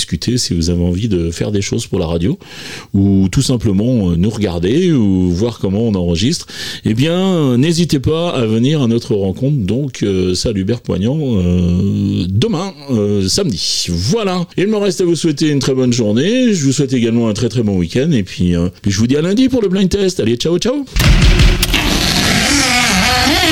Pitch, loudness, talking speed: 120 Hz, -14 LUFS, 185 wpm